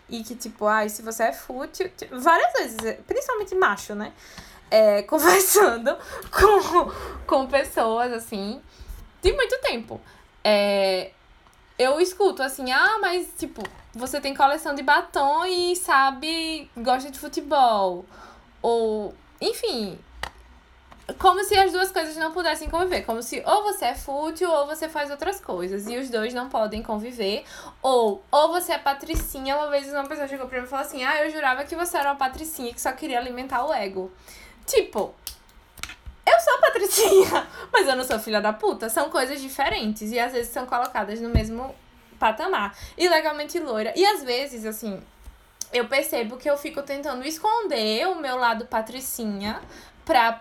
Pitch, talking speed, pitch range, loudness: 275 Hz, 160 wpm, 230-335 Hz, -23 LUFS